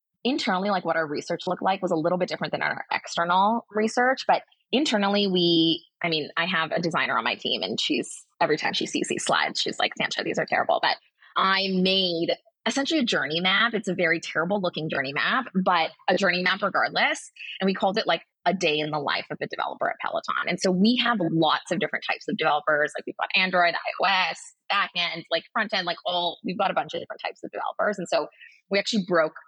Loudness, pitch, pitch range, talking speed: -24 LUFS, 180 Hz, 165-200 Hz, 230 wpm